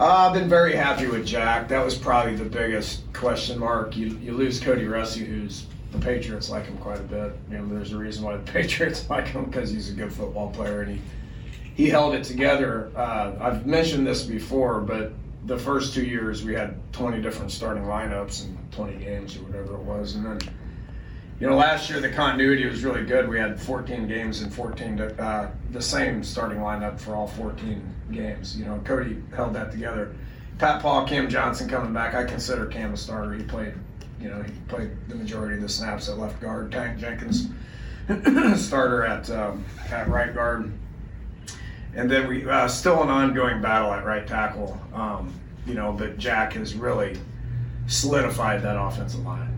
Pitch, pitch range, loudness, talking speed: 110 Hz, 105-125 Hz, -25 LUFS, 190 wpm